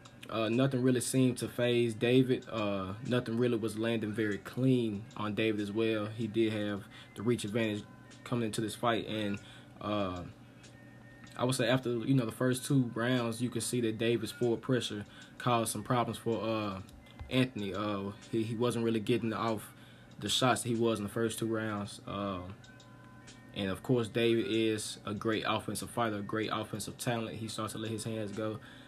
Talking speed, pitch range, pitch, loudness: 190 wpm, 110-120 Hz, 115 Hz, -33 LUFS